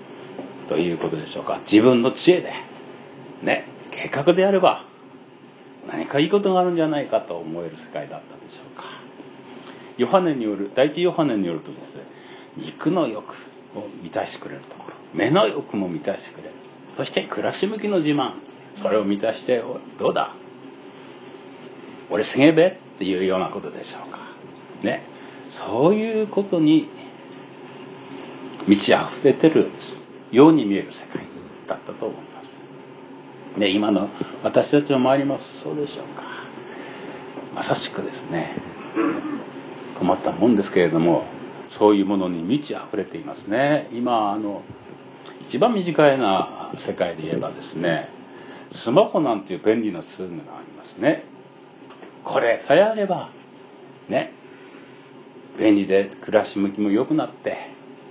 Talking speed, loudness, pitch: 285 characters per minute, -21 LUFS, 140 Hz